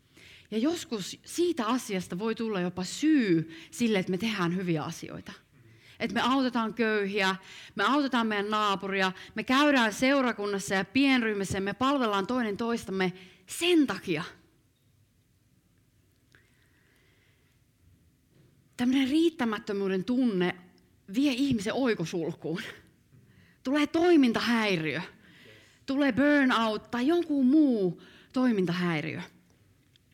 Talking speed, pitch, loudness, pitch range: 95 wpm, 215 Hz, -28 LUFS, 185-260 Hz